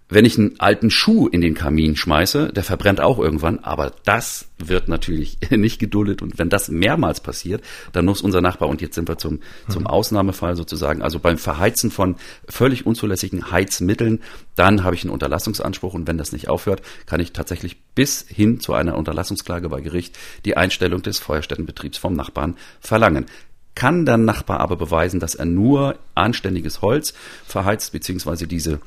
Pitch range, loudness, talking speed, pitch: 80-100 Hz, -19 LUFS, 175 wpm, 90 Hz